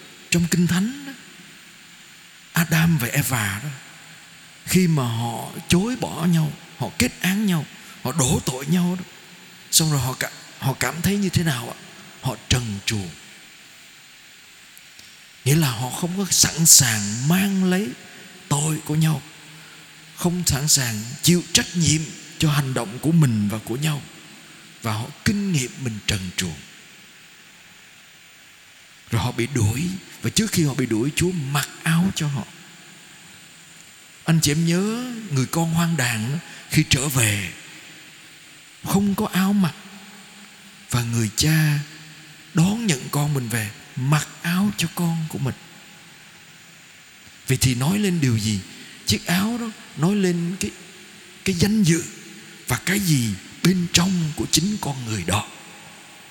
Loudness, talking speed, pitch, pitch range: -21 LUFS, 145 wpm, 160 Hz, 130-180 Hz